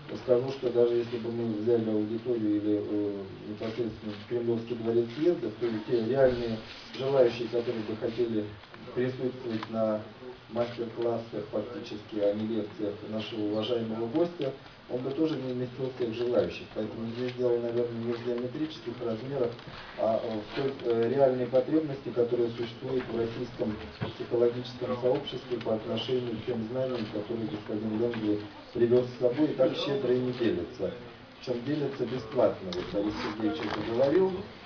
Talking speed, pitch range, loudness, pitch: 145 wpm, 110-125 Hz, -30 LUFS, 120 Hz